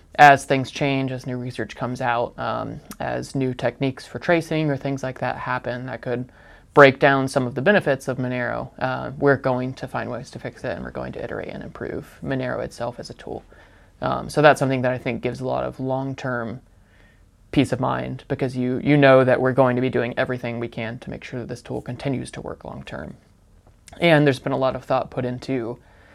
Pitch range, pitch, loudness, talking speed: 120-135 Hz, 130 Hz, -22 LUFS, 225 wpm